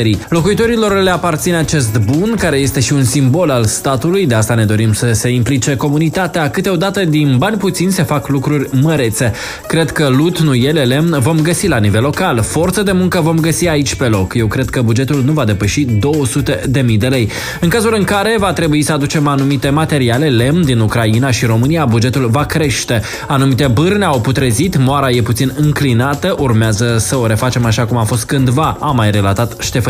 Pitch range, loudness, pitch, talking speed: 120-160 Hz, -13 LUFS, 140 Hz, 195 wpm